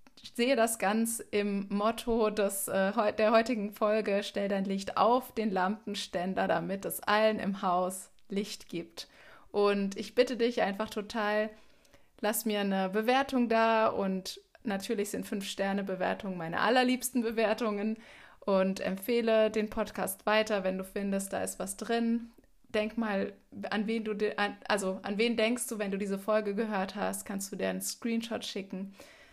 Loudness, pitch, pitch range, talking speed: -31 LUFS, 210 Hz, 195-225 Hz, 155 wpm